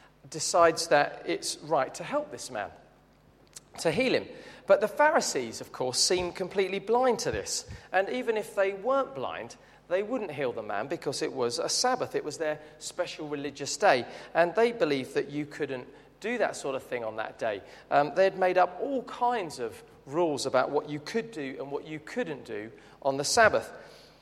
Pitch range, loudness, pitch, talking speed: 155-260 Hz, -29 LUFS, 195 Hz, 195 wpm